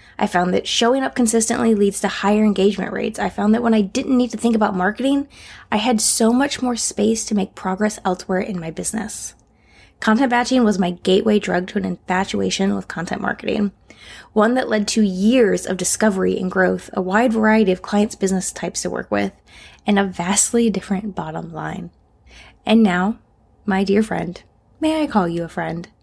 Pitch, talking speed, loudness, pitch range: 205 Hz, 190 wpm, -19 LUFS, 185-225 Hz